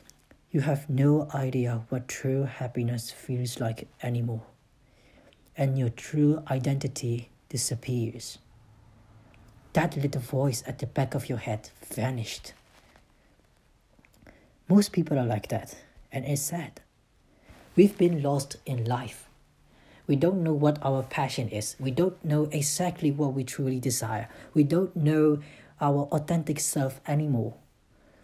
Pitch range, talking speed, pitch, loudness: 120-150 Hz, 125 wpm, 135 Hz, -28 LUFS